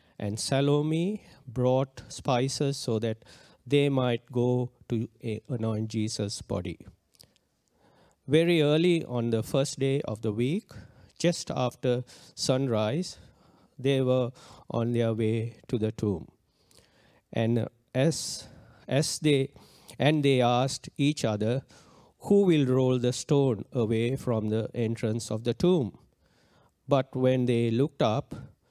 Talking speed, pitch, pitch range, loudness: 125 wpm, 125 Hz, 115-140 Hz, -28 LUFS